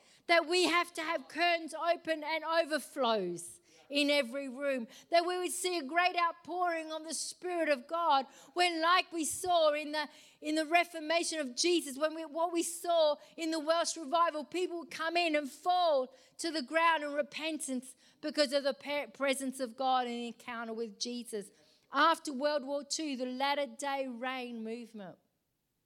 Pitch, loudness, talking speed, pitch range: 305 Hz, -33 LUFS, 170 wpm, 265-330 Hz